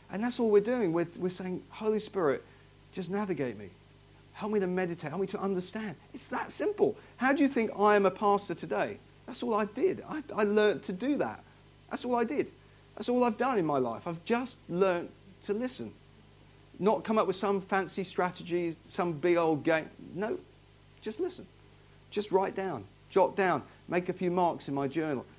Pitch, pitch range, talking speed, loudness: 195 Hz, 175-220 Hz, 200 wpm, -31 LUFS